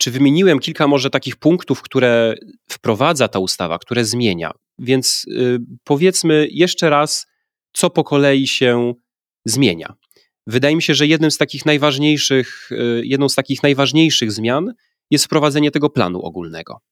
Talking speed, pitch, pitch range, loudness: 140 wpm, 140 Hz, 120-150 Hz, -16 LUFS